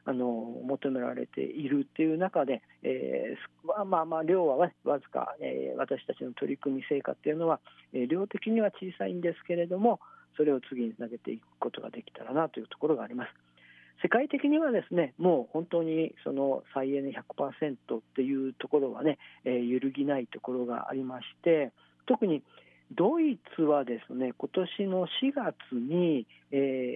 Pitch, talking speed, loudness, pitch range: 145 Hz, 330 characters per minute, -31 LUFS, 130-180 Hz